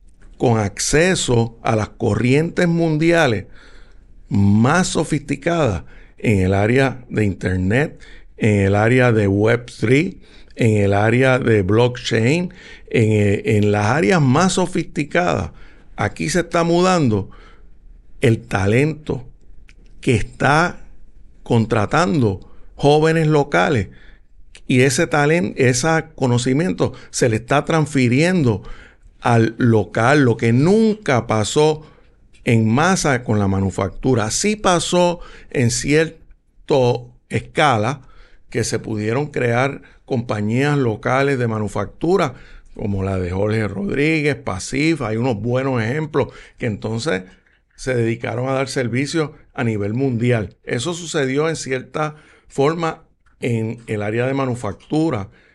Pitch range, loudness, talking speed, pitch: 105-150 Hz, -18 LUFS, 110 wpm, 125 Hz